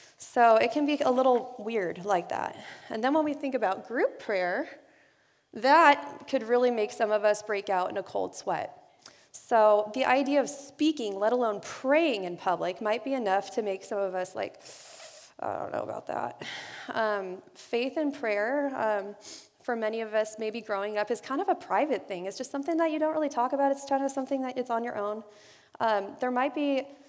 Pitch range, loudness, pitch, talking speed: 210-280 Hz, -28 LUFS, 245 Hz, 210 wpm